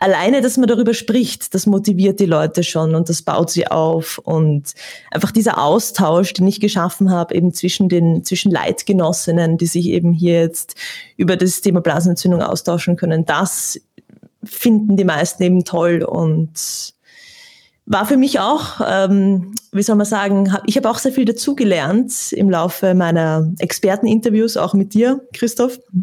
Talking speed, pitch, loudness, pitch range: 160 wpm, 190 Hz, -16 LUFS, 170-225 Hz